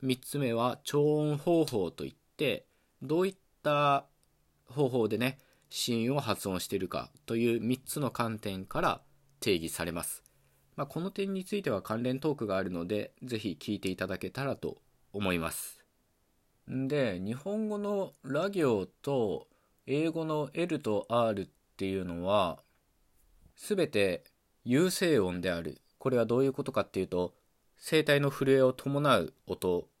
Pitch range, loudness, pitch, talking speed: 105-150 Hz, -32 LUFS, 130 Hz, 270 characters per minute